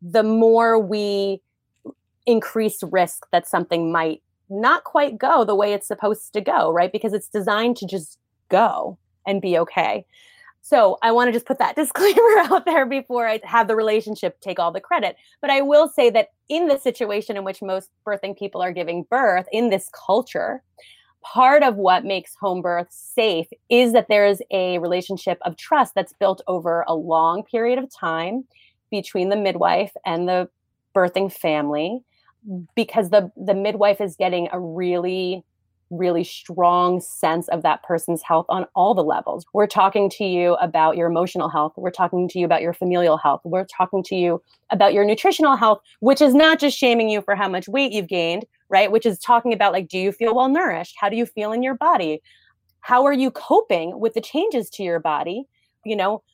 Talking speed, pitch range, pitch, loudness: 190 wpm, 180-235 Hz, 200 Hz, -20 LUFS